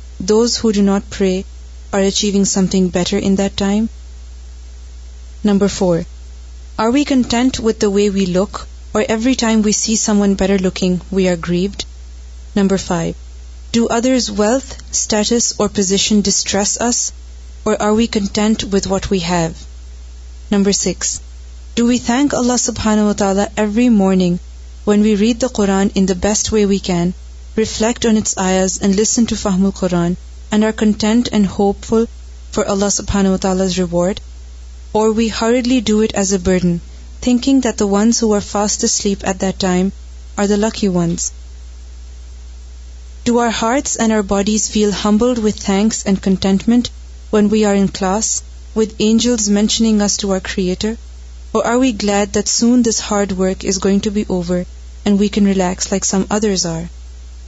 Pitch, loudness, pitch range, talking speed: 200 Hz, -15 LUFS, 170-215 Hz, 140 wpm